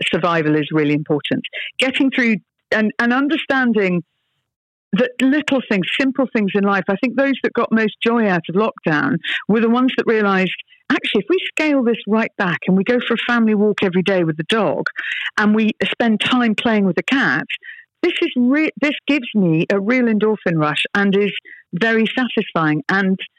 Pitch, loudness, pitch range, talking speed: 220 Hz, -17 LUFS, 195-255 Hz, 185 wpm